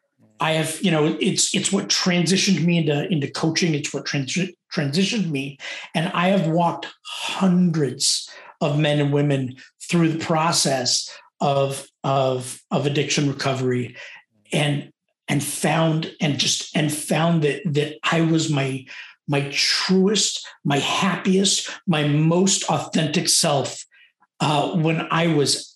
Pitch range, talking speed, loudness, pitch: 145-180 Hz, 135 wpm, -21 LUFS, 160 Hz